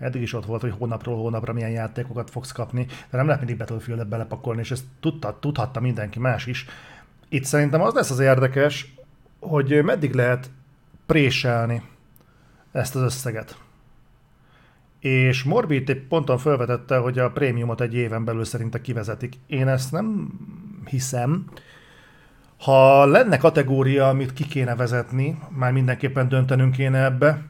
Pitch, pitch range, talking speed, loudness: 130 Hz, 120-145 Hz, 140 wpm, -22 LUFS